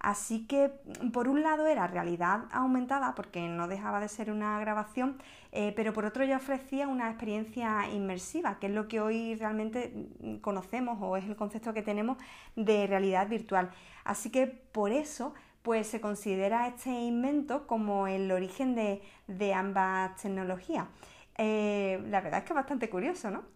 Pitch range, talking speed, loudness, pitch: 200-255 Hz, 165 wpm, -33 LUFS, 215 Hz